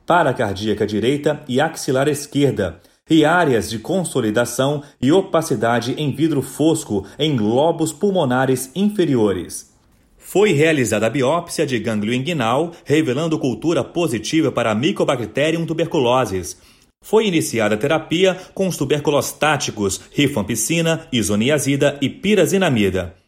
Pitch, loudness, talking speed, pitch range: 145 Hz, -18 LUFS, 115 wpm, 120-160 Hz